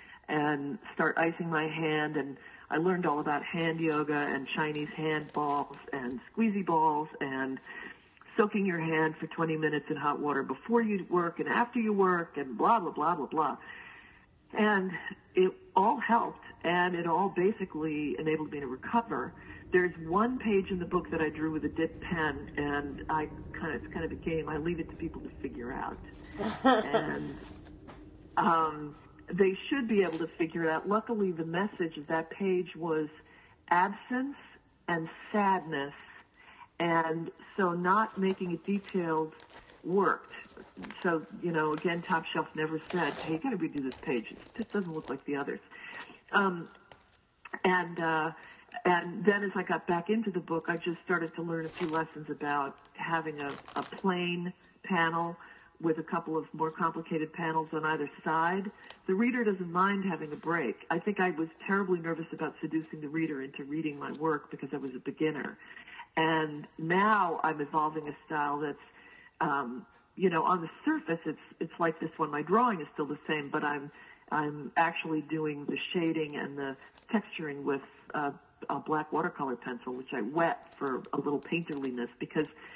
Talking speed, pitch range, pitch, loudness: 175 wpm, 150-185 Hz, 160 Hz, -32 LUFS